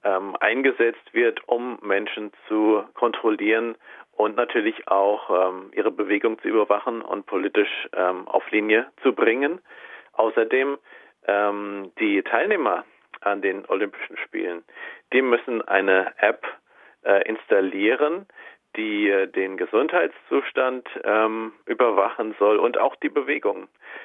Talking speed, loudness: 115 wpm, -23 LUFS